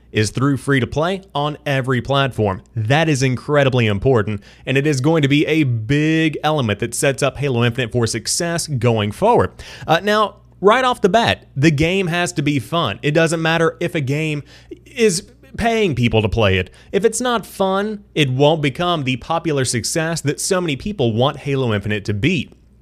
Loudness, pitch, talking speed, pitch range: -18 LUFS, 145 Hz, 190 wpm, 120-165 Hz